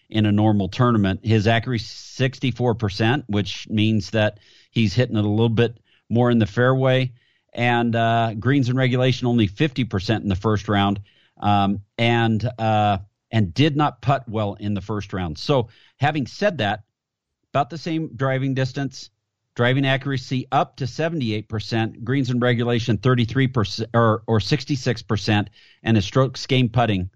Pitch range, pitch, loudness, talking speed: 105-130 Hz, 115 Hz, -21 LUFS, 150 wpm